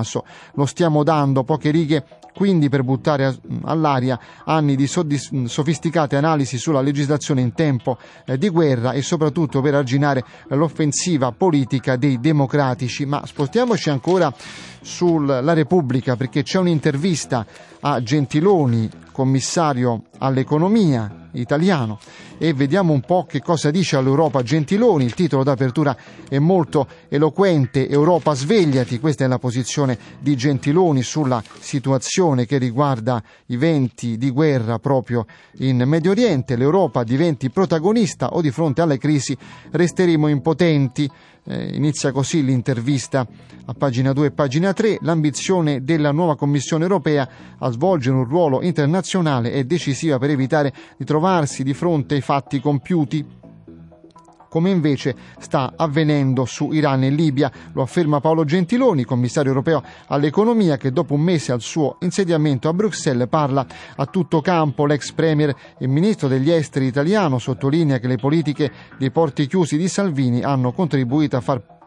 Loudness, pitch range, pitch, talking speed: -19 LUFS, 135-165 Hz, 145 Hz, 135 wpm